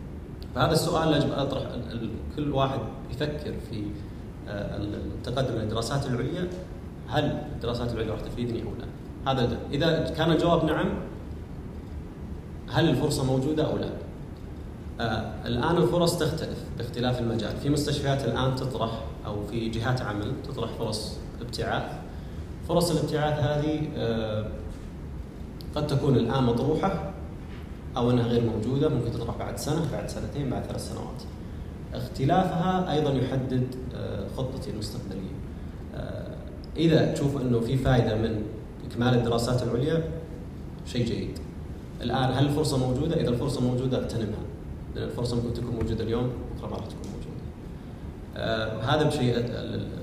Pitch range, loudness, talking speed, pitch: 105-140 Hz, -28 LUFS, 125 wpm, 120 Hz